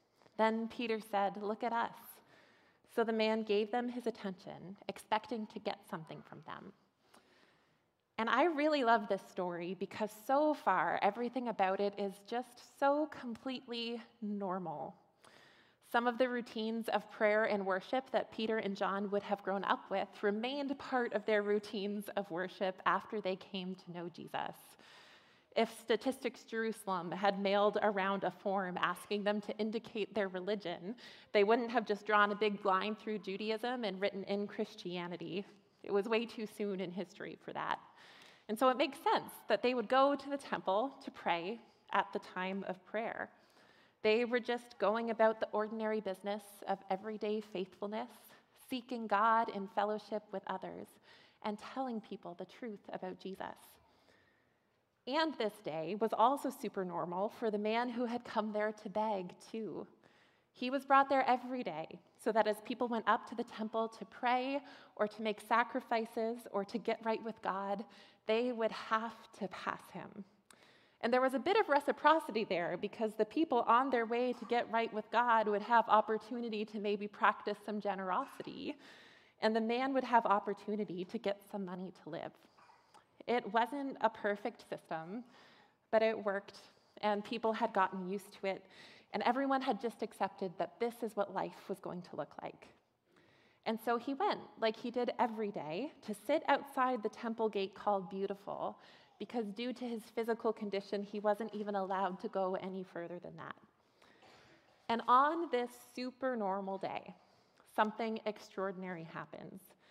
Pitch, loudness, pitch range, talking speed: 215 Hz, -37 LUFS, 200-235 Hz, 170 wpm